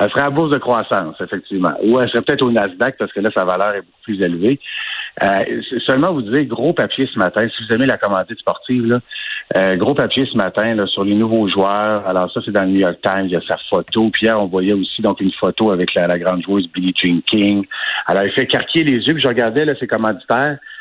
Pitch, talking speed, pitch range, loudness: 110 Hz, 255 wpm, 95-125 Hz, -16 LUFS